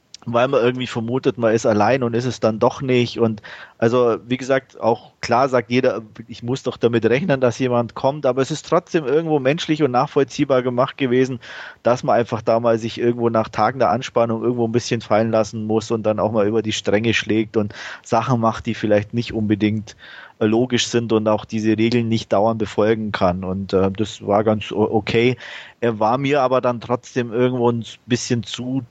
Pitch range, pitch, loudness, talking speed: 110-125 Hz, 115 Hz, -19 LUFS, 200 wpm